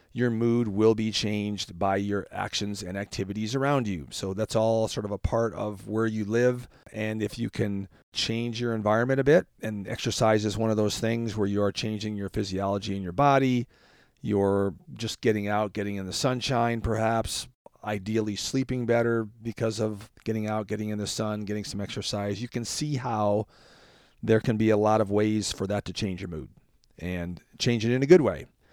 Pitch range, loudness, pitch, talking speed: 100-115 Hz, -27 LUFS, 110 Hz, 200 wpm